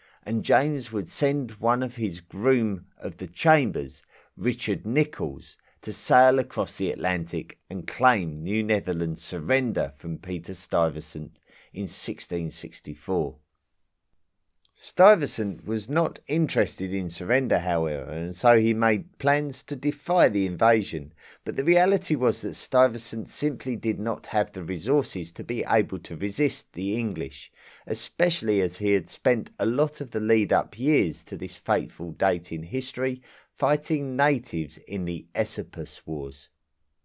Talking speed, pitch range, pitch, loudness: 145 wpm, 85-130 Hz, 105 Hz, -25 LUFS